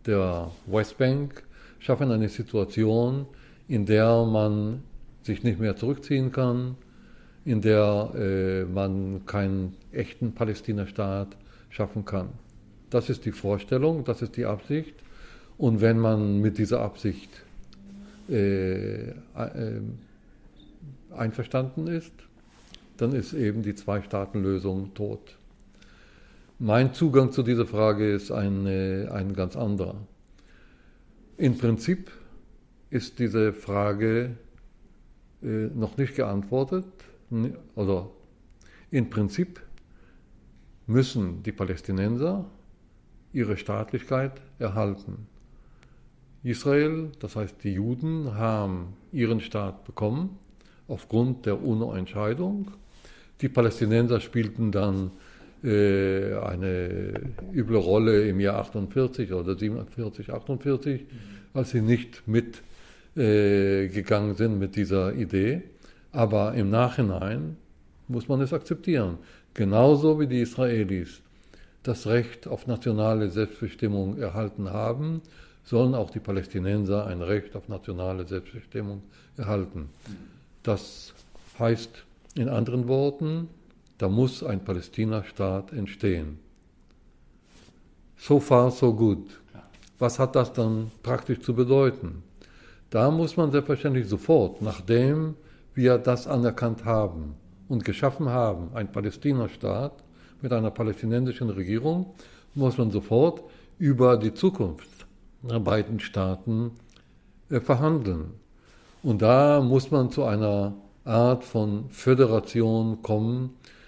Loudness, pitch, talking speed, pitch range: -26 LUFS, 110 Hz, 105 wpm, 100-125 Hz